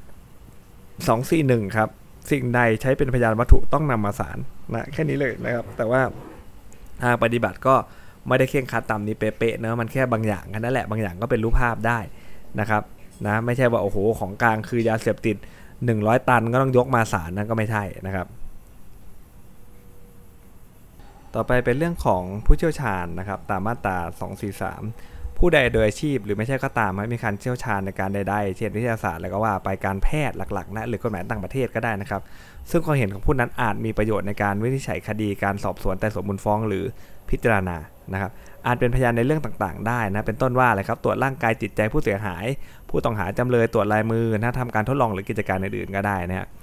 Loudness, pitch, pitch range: -23 LUFS, 110 Hz, 100-120 Hz